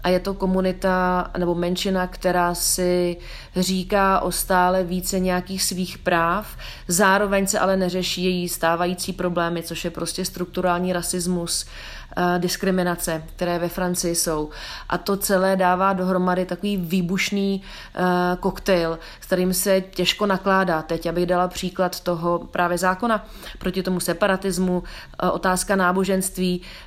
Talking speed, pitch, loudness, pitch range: 125 wpm, 180 Hz, -22 LUFS, 175-190 Hz